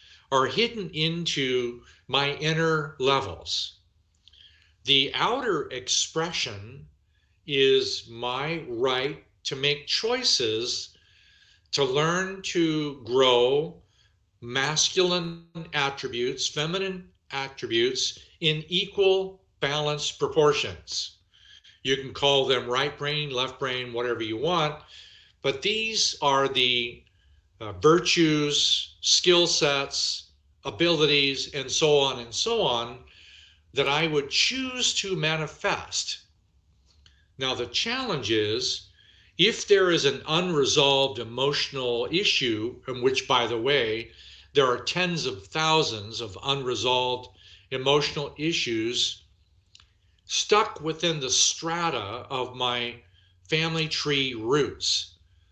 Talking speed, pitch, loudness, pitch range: 100 wpm, 135 Hz, -25 LUFS, 115-165 Hz